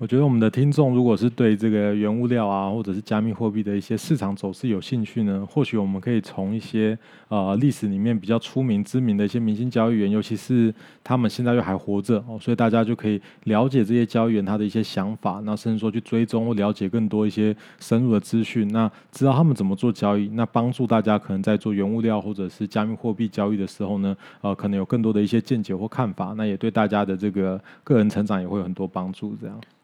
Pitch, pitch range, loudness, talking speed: 110 Hz, 100-115 Hz, -23 LUFS, 370 characters per minute